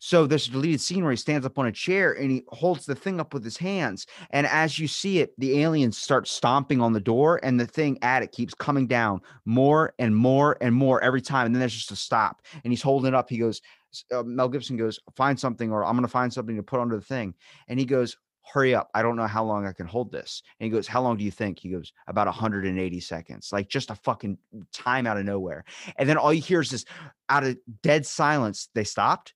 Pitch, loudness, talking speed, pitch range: 125 Hz, -25 LUFS, 260 wpm, 110-145 Hz